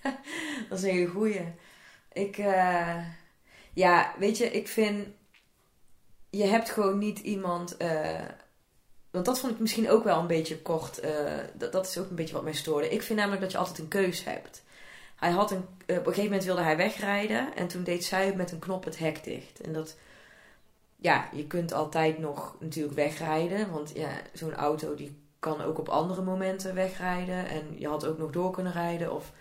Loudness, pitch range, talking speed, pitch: -30 LUFS, 160-200 Hz, 195 wpm, 180 Hz